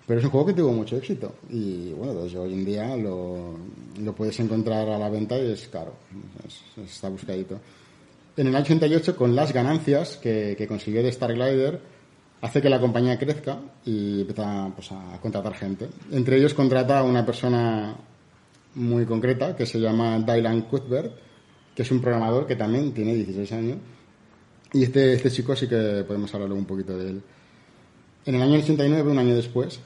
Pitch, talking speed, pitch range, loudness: 120 Hz, 185 wpm, 105-135 Hz, -24 LUFS